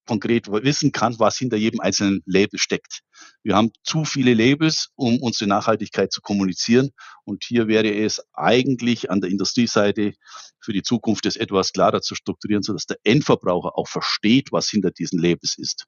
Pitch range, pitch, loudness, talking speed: 100-120 Hz, 105 Hz, -20 LUFS, 170 wpm